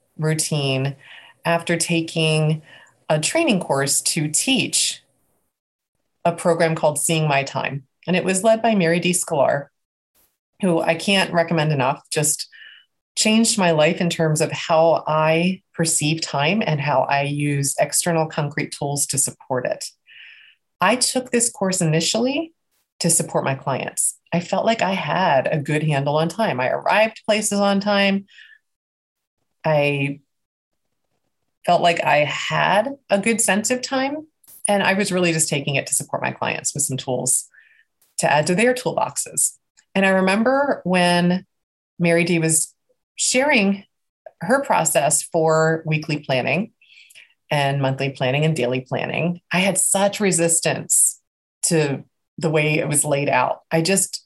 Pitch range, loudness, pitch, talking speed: 150-195 Hz, -19 LUFS, 165 Hz, 145 wpm